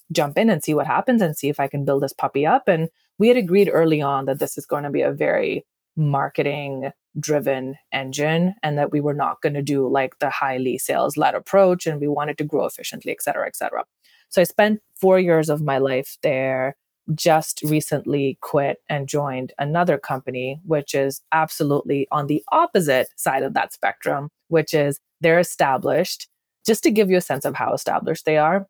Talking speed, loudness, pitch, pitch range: 205 wpm, -21 LUFS, 150 Hz, 140-170 Hz